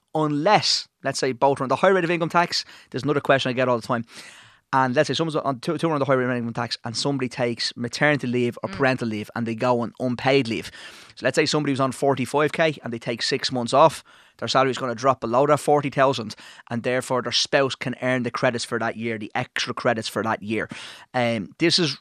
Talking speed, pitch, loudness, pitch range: 250 wpm, 130 Hz, -23 LUFS, 120-145 Hz